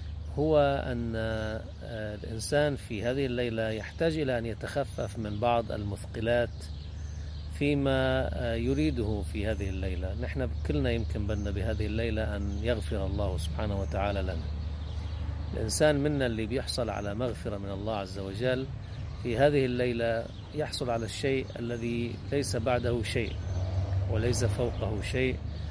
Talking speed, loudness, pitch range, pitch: 125 wpm, -31 LUFS, 95-120 Hz, 110 Hz